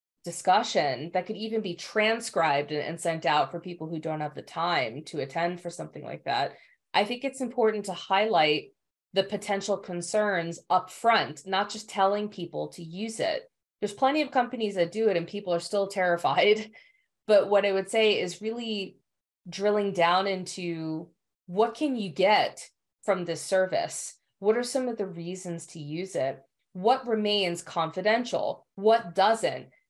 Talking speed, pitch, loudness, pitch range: 165 wpm, 195 Hz, -28 LUFS, 170-220 Hz